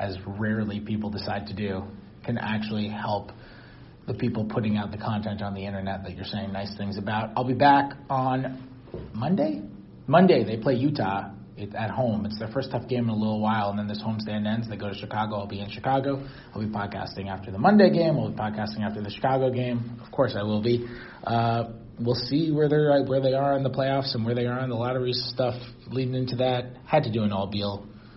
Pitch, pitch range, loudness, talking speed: 110 Hz, 105-130 Hz, -26 LUFS, 220 wpm